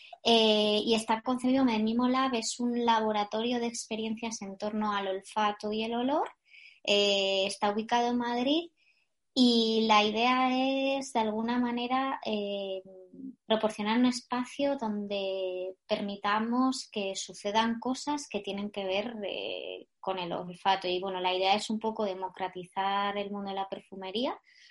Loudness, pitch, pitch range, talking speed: -30 LUFS, 220 Hz, 200-250 Hz, 145 wpm